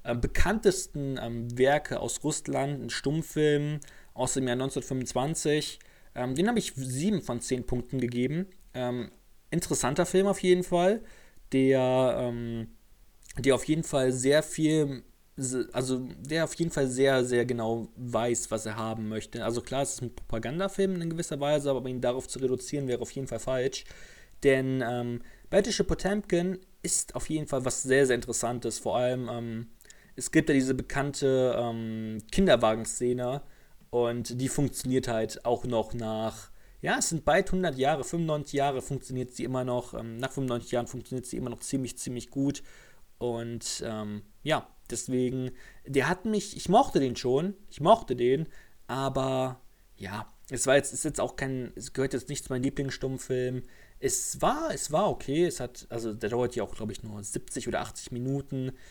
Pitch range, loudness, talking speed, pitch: 120-150 Hz, -29 LUFS, 170 wpm, 130 Hz